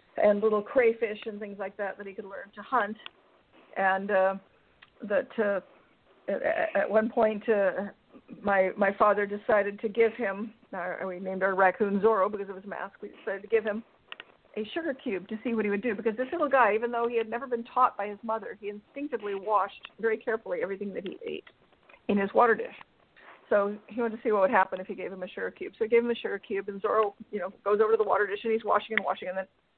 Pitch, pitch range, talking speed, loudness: 210 Hz, 200-230 Hz, 240 wpm, -28 LUFS